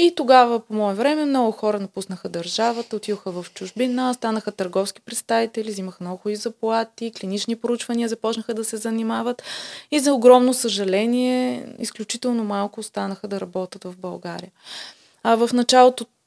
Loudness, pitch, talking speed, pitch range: -21 LUFS, 225 Hz, 145 wpm, 205-240 Hz